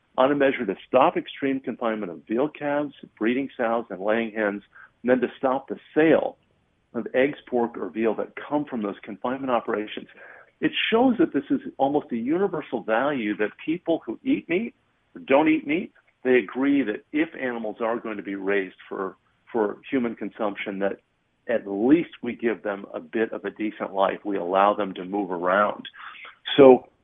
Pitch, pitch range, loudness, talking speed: 125 Hz, 105-145 Hz, -25 LUFS, 180 wpm